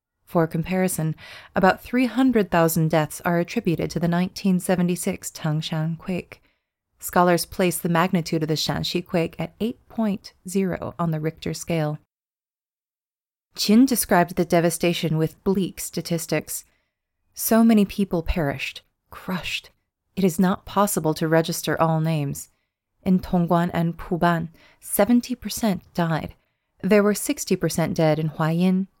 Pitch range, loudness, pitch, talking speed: 160-190 Hz, -23 LUFS, 175 Hz, 130 wpm